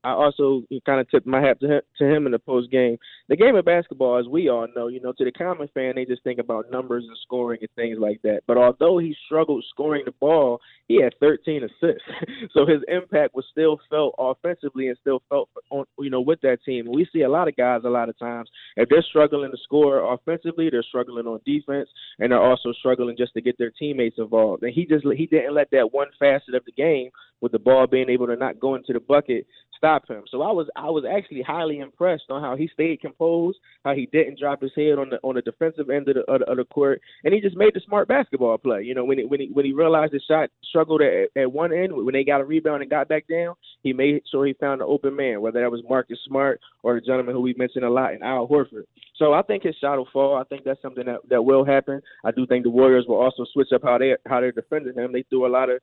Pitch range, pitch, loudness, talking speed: 125-150 Hz, 135 Hz, -22 LUFS, 260 wpm